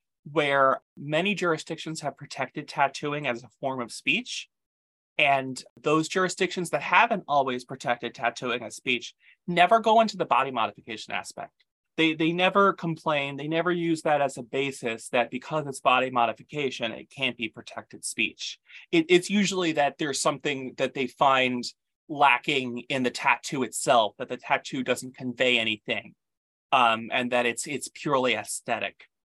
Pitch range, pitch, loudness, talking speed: 125-160 Hz, 135 Hz, -26 LUFS, 155 wpm